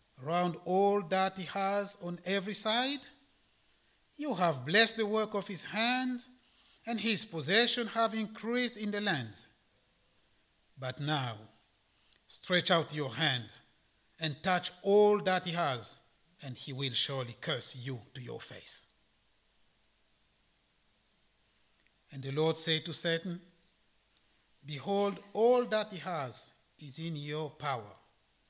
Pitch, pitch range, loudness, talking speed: 175 Hz, 135-205 Hz, -32 LUFS, 125 wpm